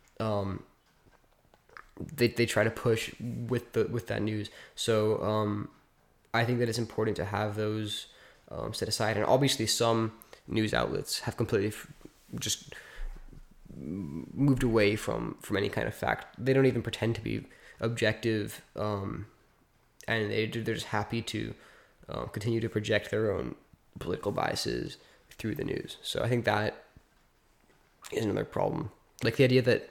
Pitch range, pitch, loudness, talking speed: 105-115 Hz, 110 Hz, -31 LUFS, 155 wpm